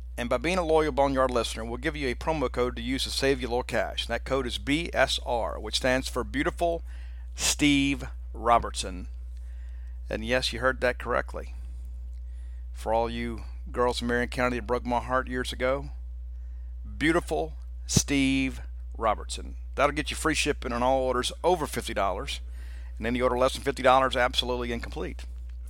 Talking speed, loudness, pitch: 175 wpm, -27 LUFS, 120 Hz